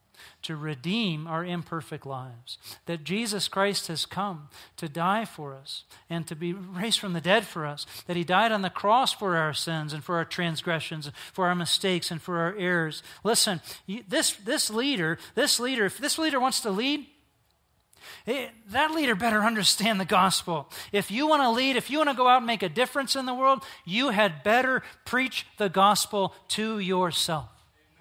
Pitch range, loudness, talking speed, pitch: 165-235 Hz, -26 LUFS, 190 wpm, 195 Hz